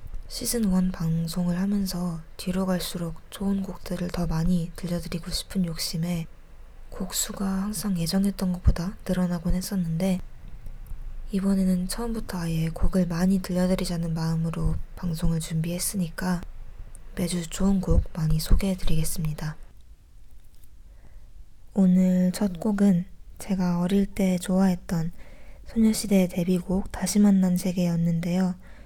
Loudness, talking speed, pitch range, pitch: -26 LUFS, 275 characters per minute, 165-190 Hz, 180 Hz